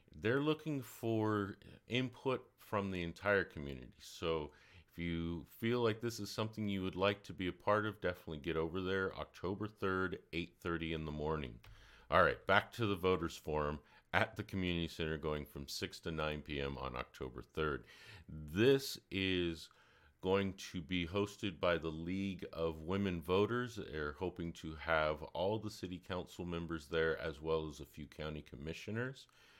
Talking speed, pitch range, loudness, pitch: 170 wpm, 80-100 Hz, -39 LUFS, 90 Hz